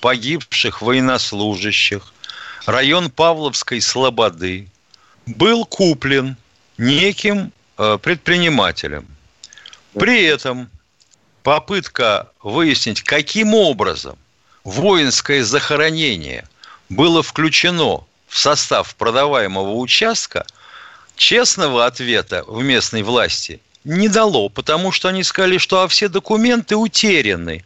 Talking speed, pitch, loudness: 85 wpm, 150 Hz, -15 LUFS